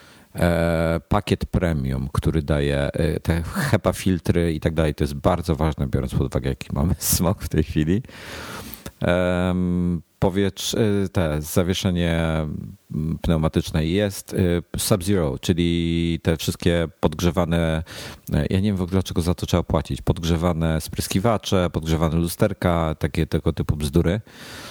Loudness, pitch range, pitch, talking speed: -22 LUFS, 80-95 Hz, 85 Hz, 135 wpm